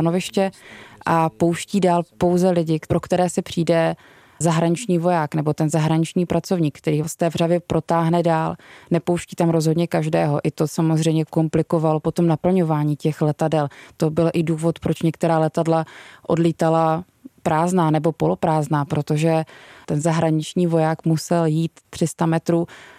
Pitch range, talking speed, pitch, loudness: 160-170 Hz, 135 wpm, 165 Hz, -20 LUFS